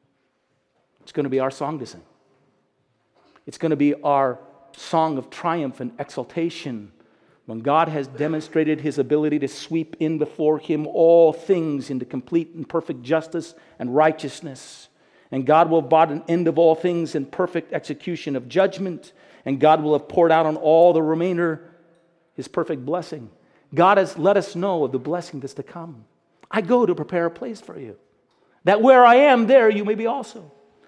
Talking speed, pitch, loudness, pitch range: 185 wpm, 160 Hz, -20 LUFS, 145-170 Hz